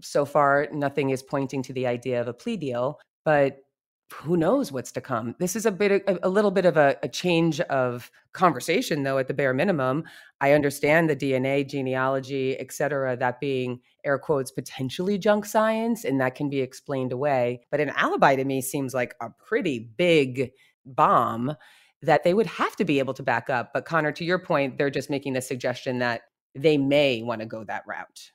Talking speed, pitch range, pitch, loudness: 200 wpm, 130-160 Hz, 140 Hz, -25 LUFS